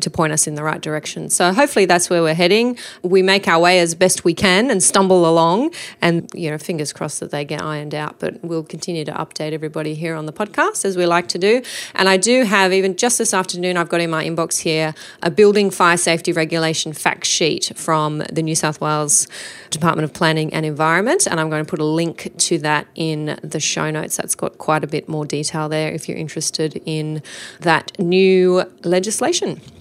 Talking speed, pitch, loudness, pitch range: 215 wpm, 165 Hz, -17 LUFS, 155-185 Hz